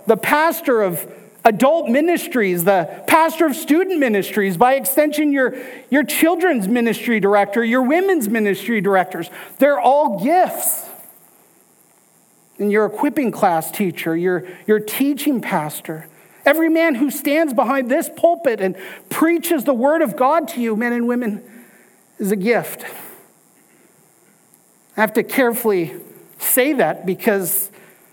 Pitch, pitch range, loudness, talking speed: 240 Hz, 200-295 Hz, -17 LUFS, 130 wpm